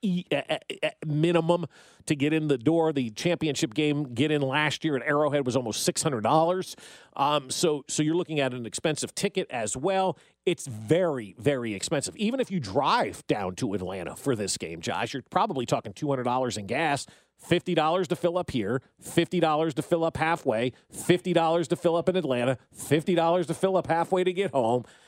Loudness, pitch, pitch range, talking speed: -27 LUFS, 155 Hz, 135-175 Hz, 175 wpm